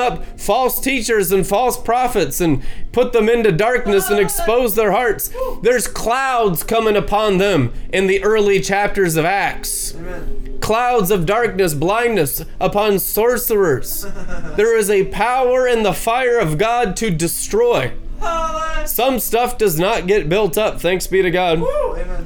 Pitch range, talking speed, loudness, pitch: 190-245 Hz, 145 wpm, -16 LUFS, 215 Hz